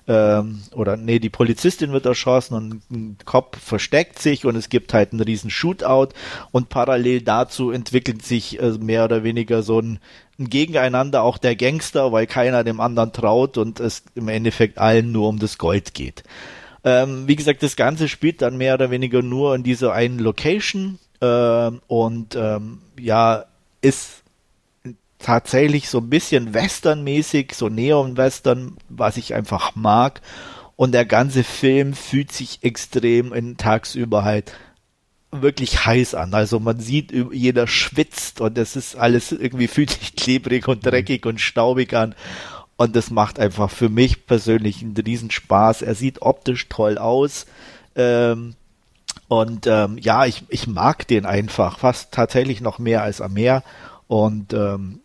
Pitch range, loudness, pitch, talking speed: 110-130 Hz, -19 LUFS, 120 Hz, 155 wpm